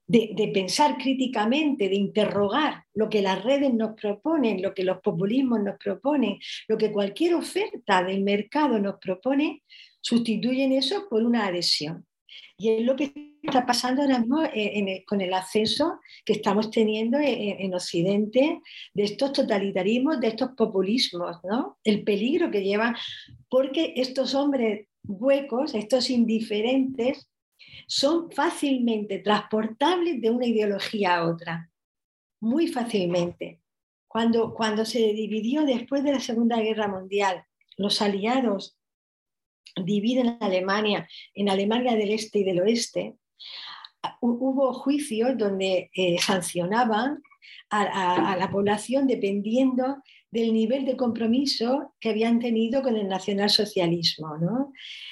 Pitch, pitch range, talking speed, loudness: 225 Hz, 200-265 Hz, 130 wpm, -25 LUFS